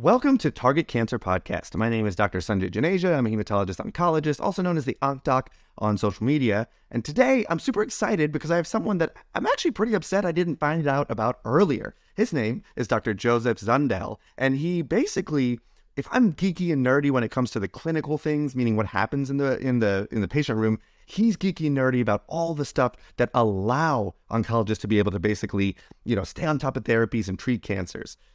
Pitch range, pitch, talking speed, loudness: 110-160 Hz, 130 Hz, 215 wpm, -25 LUFS